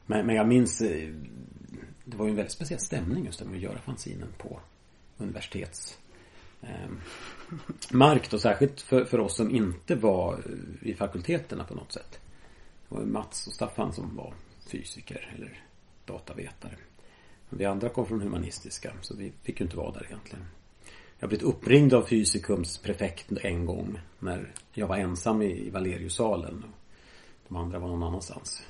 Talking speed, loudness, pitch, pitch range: 150 wpm, -29 LUFS, 105 Hz, 90-115 Hz